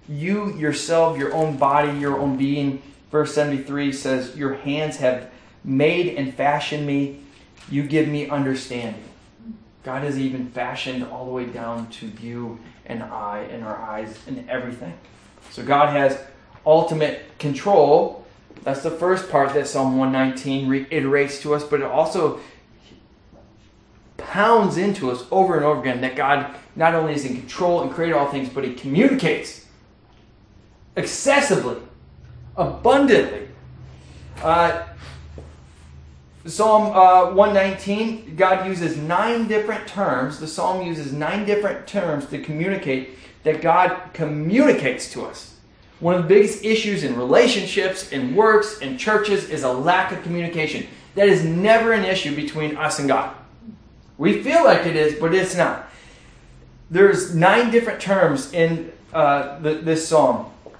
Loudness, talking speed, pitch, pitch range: -20 LUFS, 140 wpm, 150 Hz, 135-185 Hz